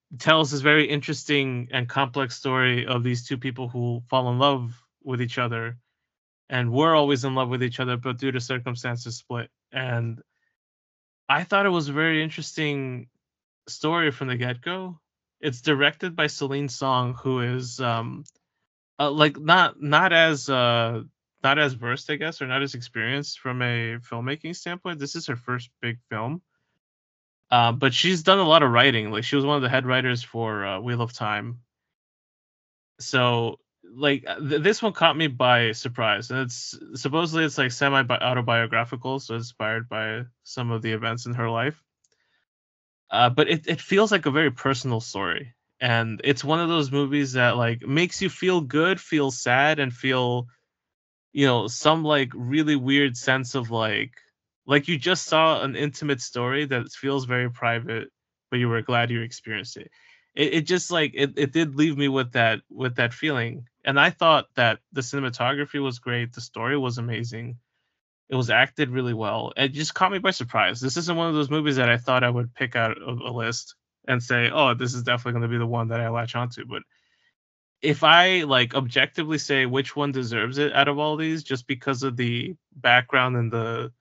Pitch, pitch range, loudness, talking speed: 130 Hz, 120-150 Hz, -23 LUFS, 190 wpm